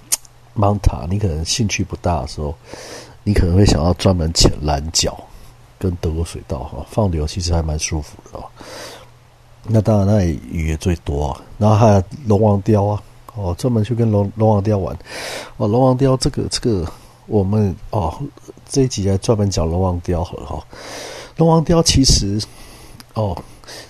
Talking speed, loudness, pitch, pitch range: 245 characters per minute, -18 LUFS, 100 Hz, 90-115 Hz